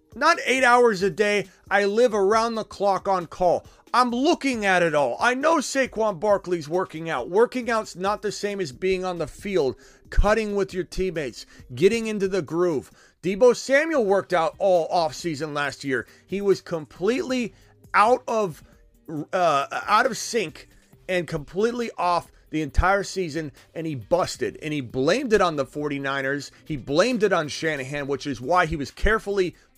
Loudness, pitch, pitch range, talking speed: -23 LUFS, 185 Hz, 160-215 Hz, 170 wpm